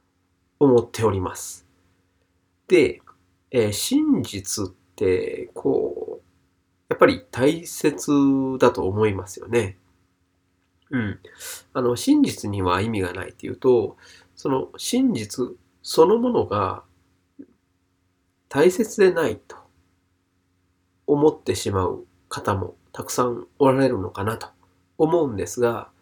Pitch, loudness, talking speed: 110 Hz, -22 LUFS, 200 characters per minute